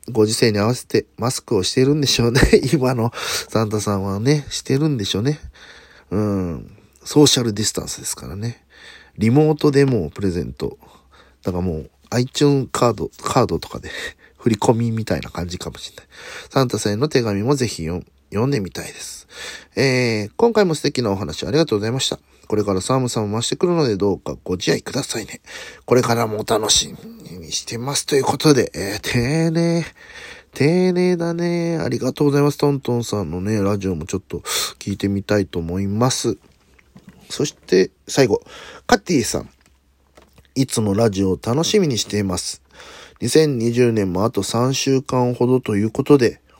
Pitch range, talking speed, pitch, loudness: 100-145 Hz, 360 characters per minute, 115 Hz, -19 LUFS